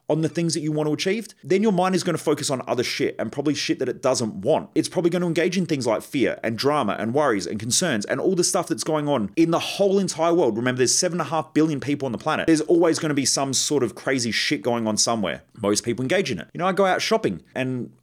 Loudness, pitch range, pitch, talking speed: -22 LUFS, 135-180 Hz, 155 Hz, 285 wpm